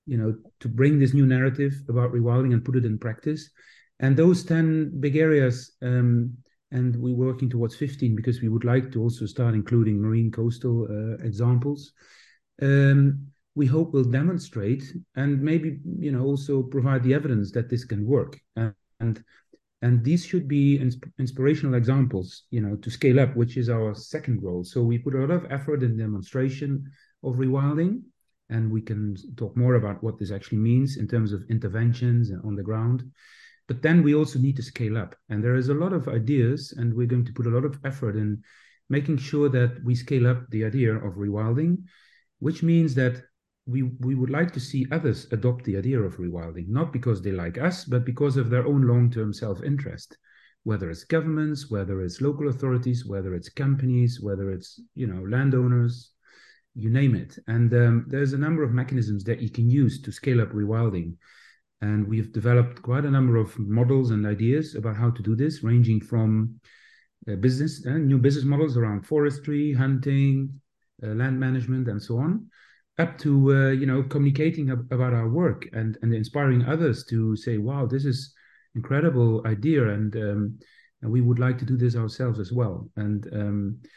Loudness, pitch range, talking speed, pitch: -24 LUFS, 115-140 Hz, 190 wpm, 125 Hz